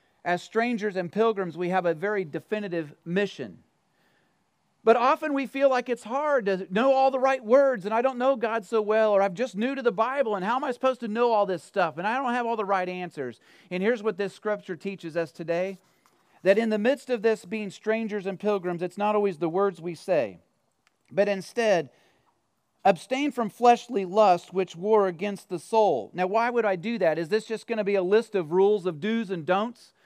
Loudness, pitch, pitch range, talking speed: -26 LUFS, 210 Hz, 185-235 Hz, 220 wpm